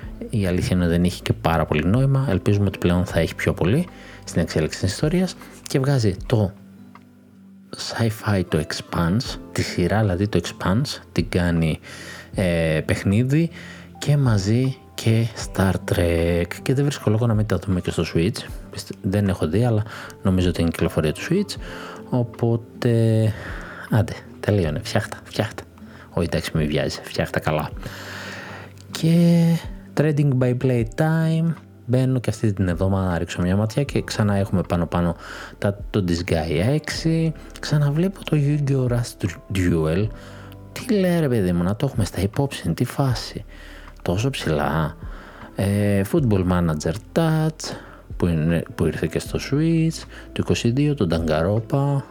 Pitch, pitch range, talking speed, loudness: 100 Hz, 90-130 Hz, 150 wpm, -22 LUFS